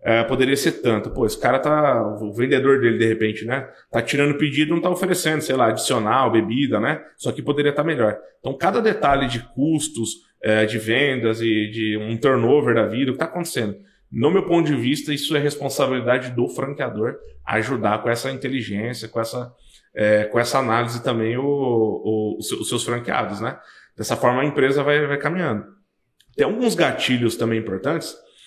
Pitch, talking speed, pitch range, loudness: 125 Hz, 190 wpm, 115-145 Hz, -21 LUFS